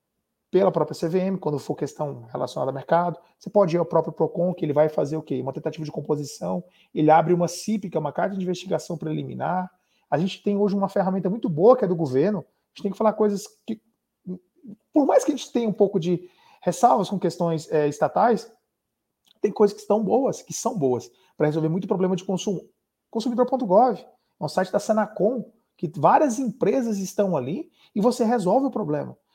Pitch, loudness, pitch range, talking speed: 185 Hz, -24 LUFS, 160-215 Hz, 205 wpm